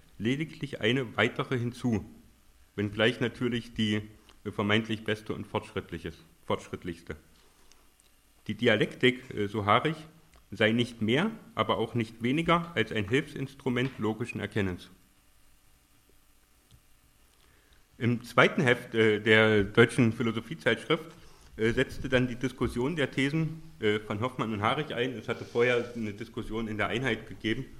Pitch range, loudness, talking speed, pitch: 105-130 Hz, -29 LUFS, 125 wpm, 115 Hz